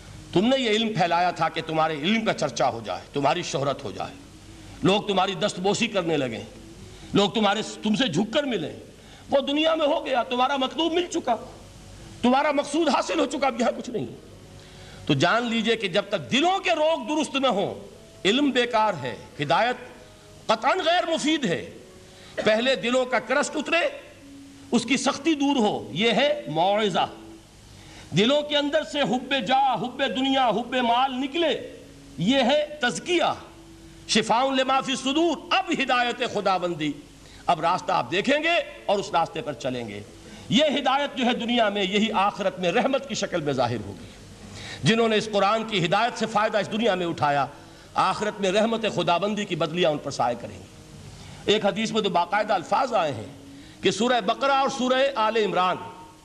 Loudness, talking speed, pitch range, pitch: -24 LUFS, 180 wpm, 175-270 Hz, 220 Hz